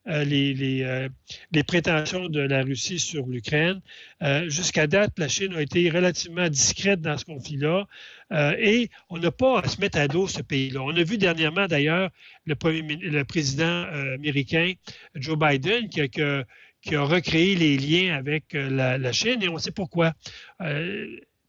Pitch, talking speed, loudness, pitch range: 155 Hz, 175 wpm, -24 LUFS, 145-180 Hz